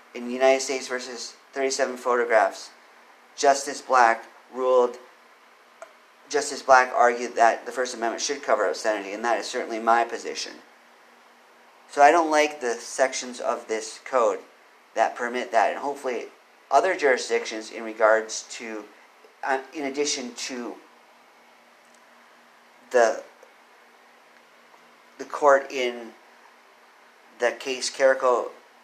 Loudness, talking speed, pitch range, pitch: -24 LUFS, 115 wpm, 115-135 Hz, 125 Hz